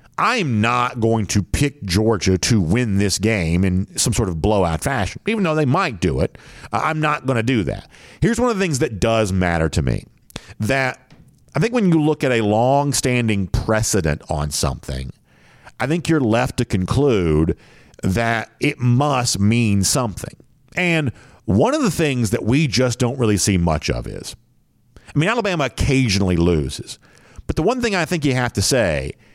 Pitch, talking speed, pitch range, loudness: 120 Hz, 185 wpm, 100-145 Hz, -19 LUFS